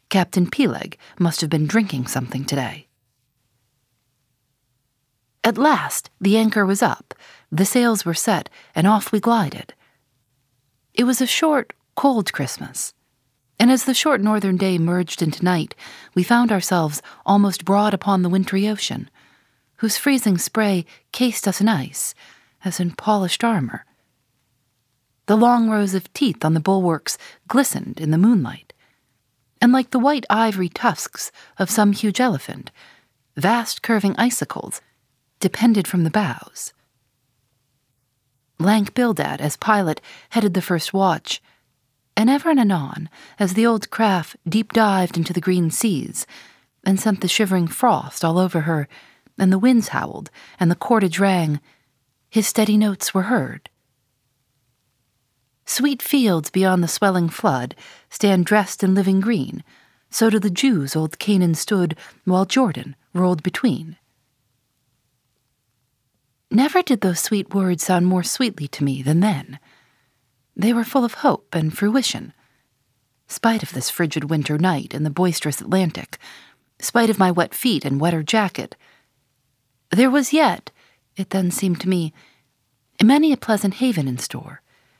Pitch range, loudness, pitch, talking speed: 135-215 Hz, -19 LUFS, 185 Hz, 145 wpm